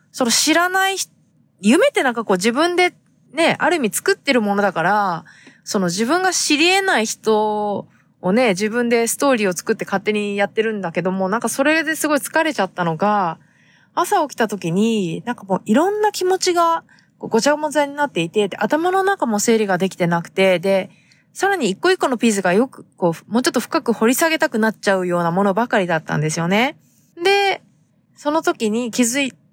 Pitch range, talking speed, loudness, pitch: 195-315 Hz, 390 characters per minute, -18 LUFS, 230 Hz